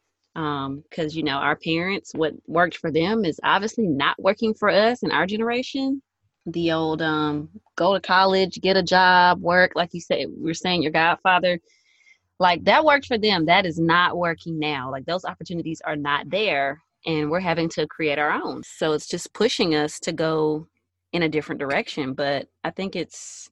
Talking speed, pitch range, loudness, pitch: 190 wpm, 155-190 Hz, -22 LUFS, 165 Hz